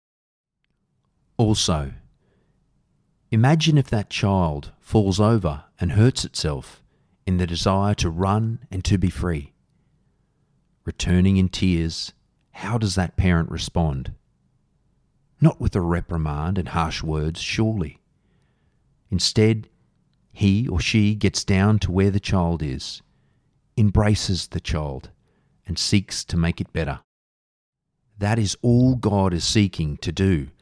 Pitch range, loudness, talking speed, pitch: 85-110 Hz, -22 LUFS, 125 wpm, 95 Hz